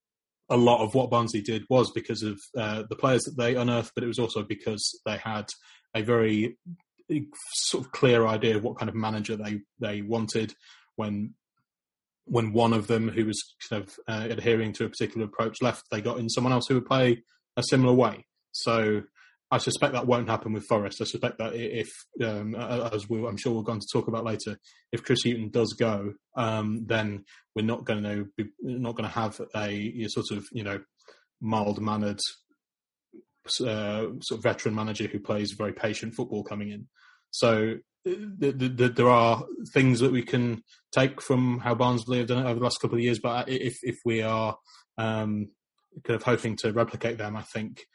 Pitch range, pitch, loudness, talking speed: 110-120 Hz, 115 Hz, -28 LUFS, 200 wpm